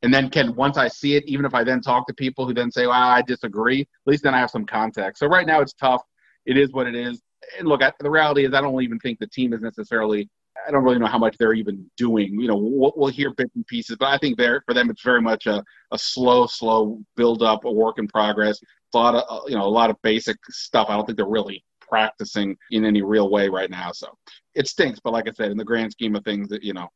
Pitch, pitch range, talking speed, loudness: 120 Hz, 110-135 Hz, 275 wpm, -21 LUFS